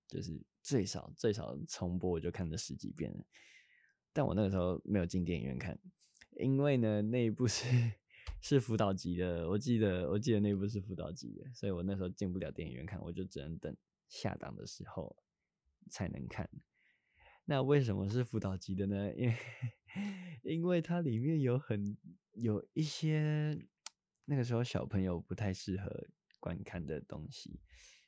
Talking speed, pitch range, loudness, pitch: 255 characters per minute, 95-130 Hz, -37 LUFS, 105 Hz